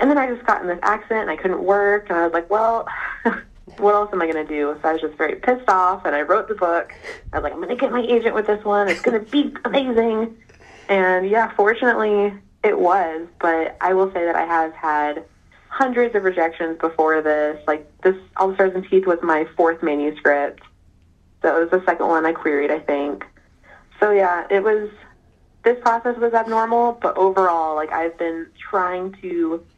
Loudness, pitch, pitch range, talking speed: -20 LUFS, 185 Hz, 160-215 Hz, 215 wpm